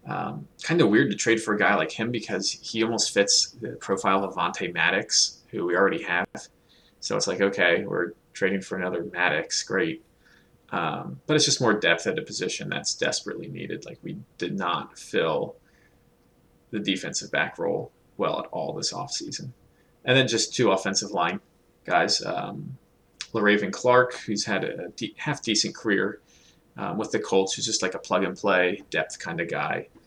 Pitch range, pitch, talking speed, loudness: 100-125 Hz, 110 Hz, 185 wpm, -25 LUFS